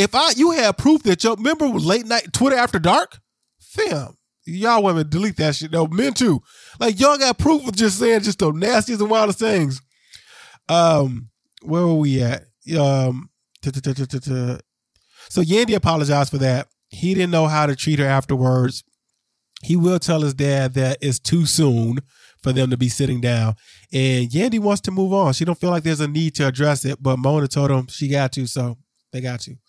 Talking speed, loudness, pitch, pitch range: 210 wpm, -19 LUFS, 150 Hz, 130-195 Hz